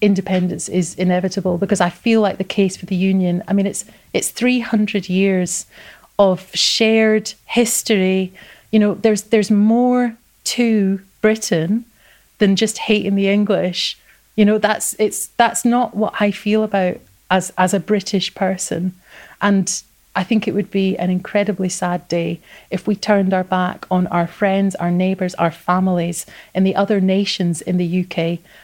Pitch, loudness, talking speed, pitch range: 195 Hz, -18 LUFS, 160 wpm, 185-215 Hz